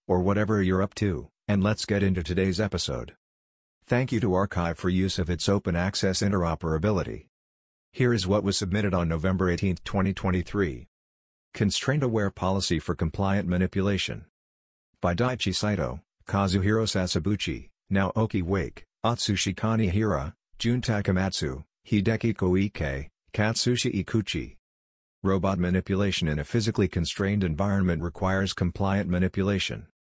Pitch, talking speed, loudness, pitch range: 95 Hz, 125 wpm, -27 LUFS, 85-105 Hz